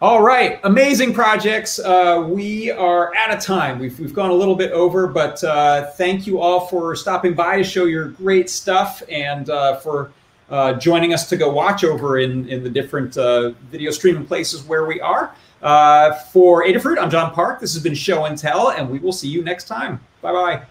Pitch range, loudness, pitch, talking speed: 145-185 Hz, -17 LUFS, 170 Hz, 210 wpm